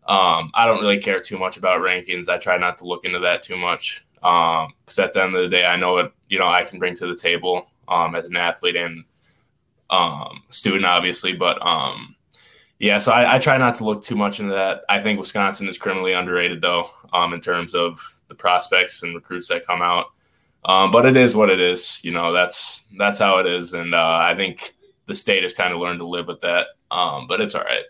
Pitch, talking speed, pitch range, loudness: 90 Hz, 235 wpm, 90-100 Hz, -19 LUFS